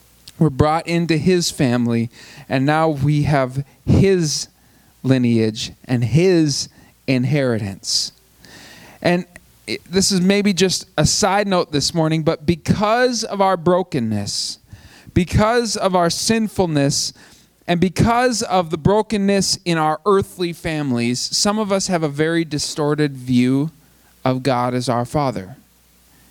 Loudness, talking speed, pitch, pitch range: -18 LUFS, 125 wpm, 155 Hz, 130-185 Hz